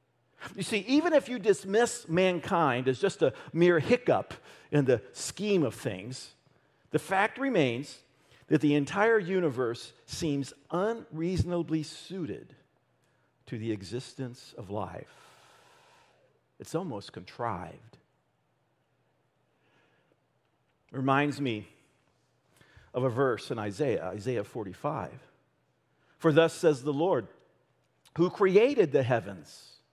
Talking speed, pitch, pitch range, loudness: 110 wpm, 155 Hz, 135-190 Hz, -29 LUFS